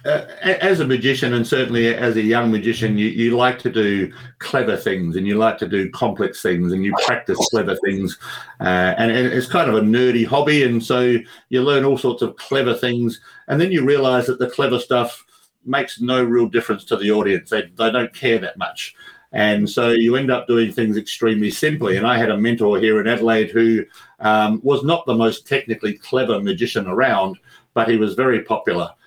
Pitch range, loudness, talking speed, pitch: 110-125 Hz, -18 LUFS, 205 wpm, 115 Hz